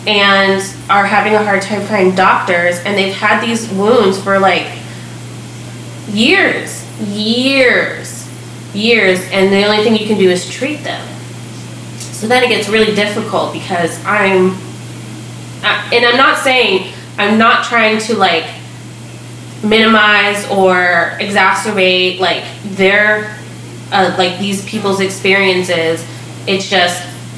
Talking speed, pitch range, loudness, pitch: 125 wpm, 185-215 Hz, -11 LUFS, 195 Hz